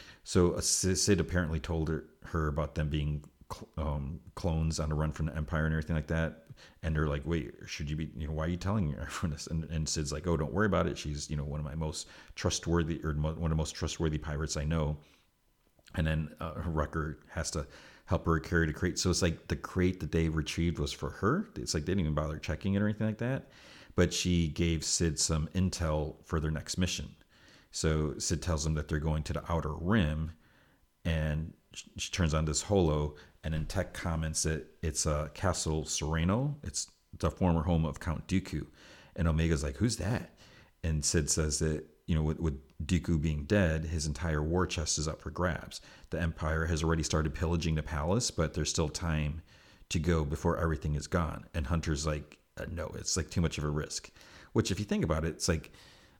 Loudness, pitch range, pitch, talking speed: -33 LUFS, 75-85 Hz, 80 Hz, 215 wpm